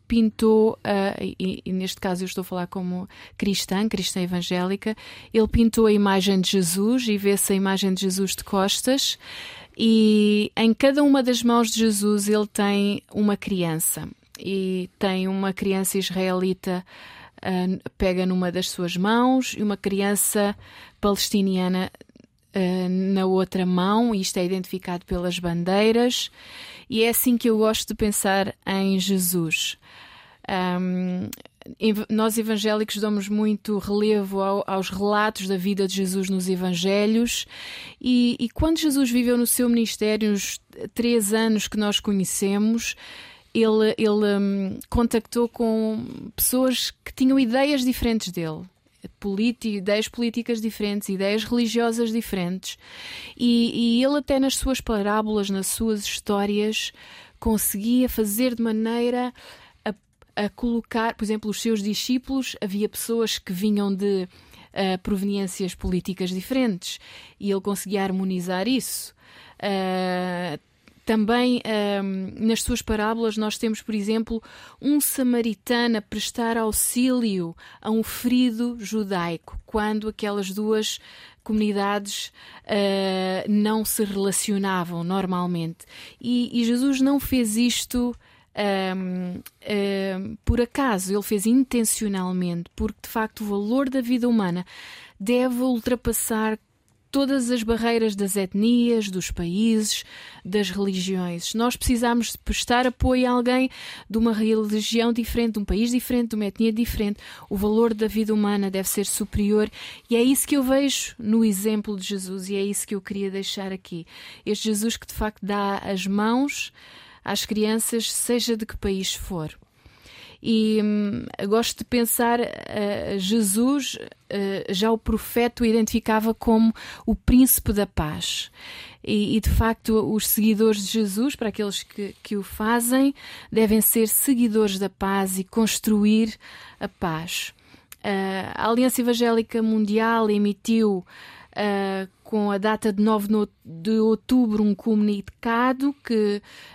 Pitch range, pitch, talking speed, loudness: 195-230 Hz, 215 Hz, 135 wpm, -23 LUFS